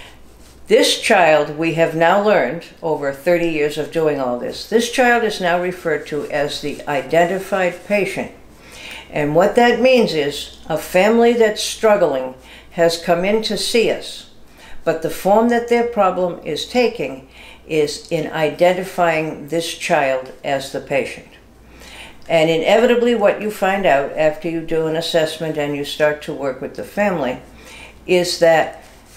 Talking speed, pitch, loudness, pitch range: 155 wpm, 165 Hz, -17 LUFS, 150-200 Hz